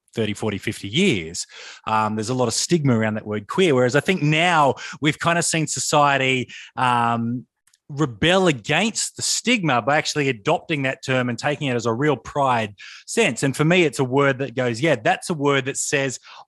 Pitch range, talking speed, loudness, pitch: 120-155 Hz, 200 wpm, -20 LUFS, 140 Hz